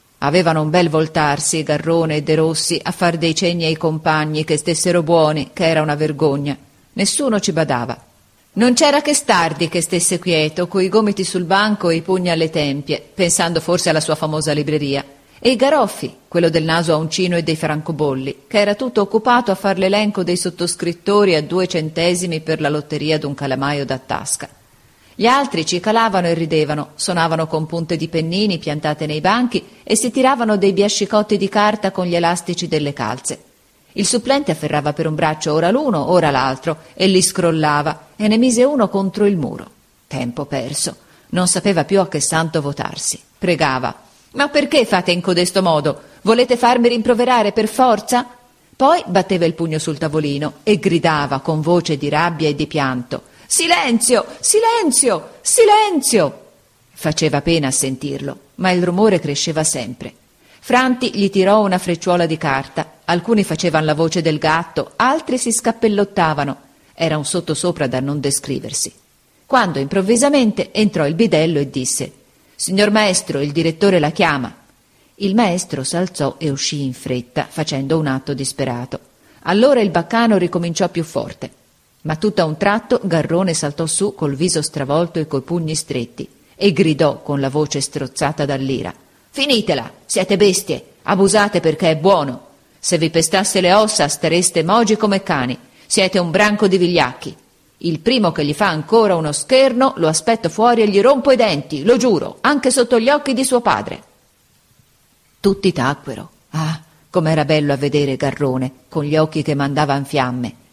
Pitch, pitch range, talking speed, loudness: 170 Hz, 150-200 Hz, 165 wpm, -16 LUFS